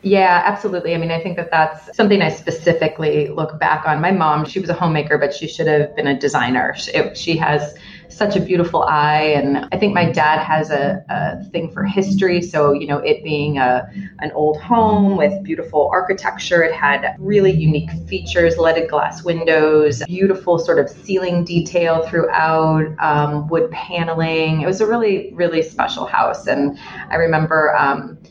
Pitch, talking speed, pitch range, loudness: 165 Hz, 180 wpm, 150-180 Hz, -17 LUFS